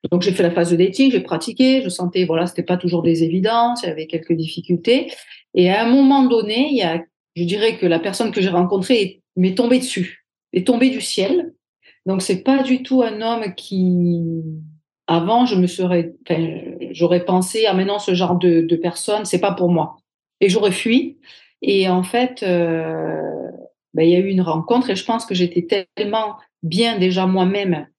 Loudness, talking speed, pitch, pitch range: -18 LUFS, 205 wpm, 185 Hz, 170-225 Hz